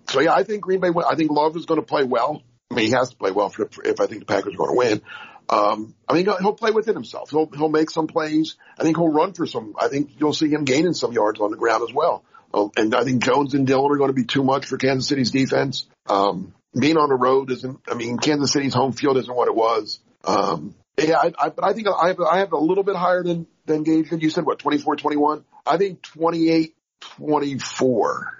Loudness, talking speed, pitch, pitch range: -21 LUFS, 255 wpm, 155 Hz, 135-170 Hz